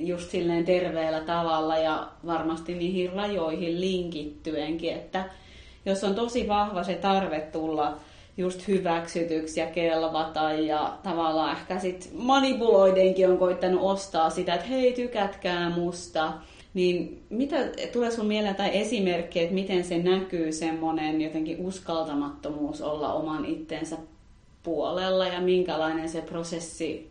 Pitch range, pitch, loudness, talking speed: 160-190 Hz, 175 Hz, -27 LUFS, 125 wpm